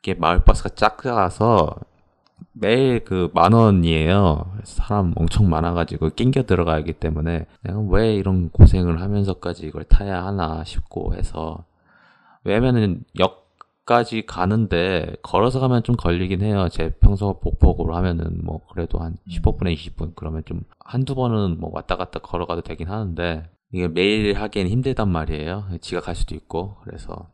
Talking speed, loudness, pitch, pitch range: 320 characters per minute, -21 LUFS, 90 Hz, 85-105 Hz